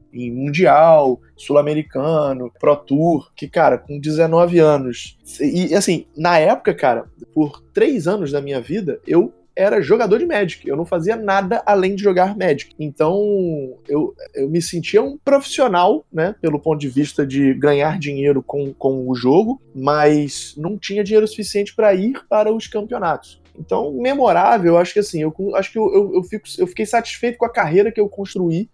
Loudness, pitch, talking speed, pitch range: -17 LUFS, 175 Hz, 175 wpm, 145-215 Hz